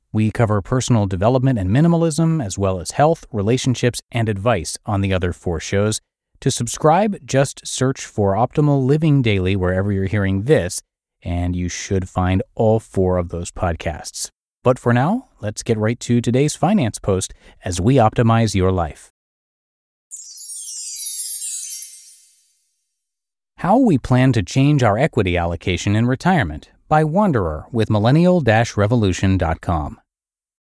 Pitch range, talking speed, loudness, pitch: 95-130 Hz, 135 wpm, -18 LUFS, 110 Hz